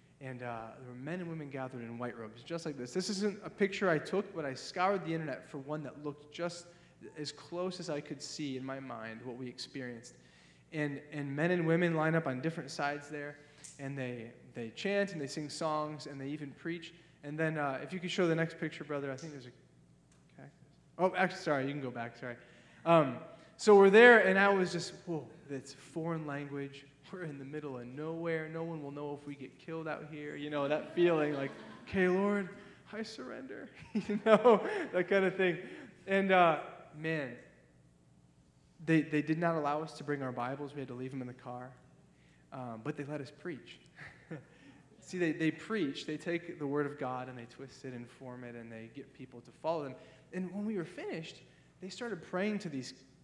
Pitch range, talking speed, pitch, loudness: 130-170 Hz, 220 wpm, 150 Hz, -34 LUFS